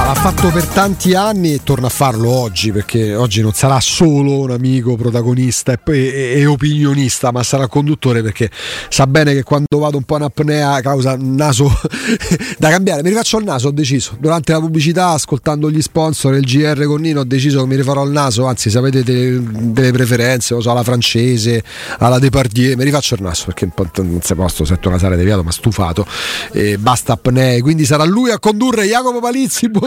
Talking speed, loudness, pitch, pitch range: 190 wpm, -13 LUFS, 135 Hz, 120-155 Hz